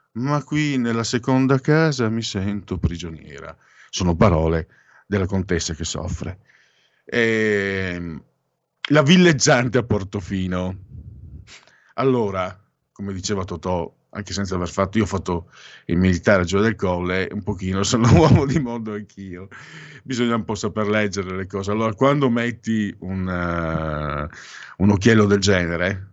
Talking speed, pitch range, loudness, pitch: 140 wpm, 90-115 Hz, -20 LUFS, 100 Hz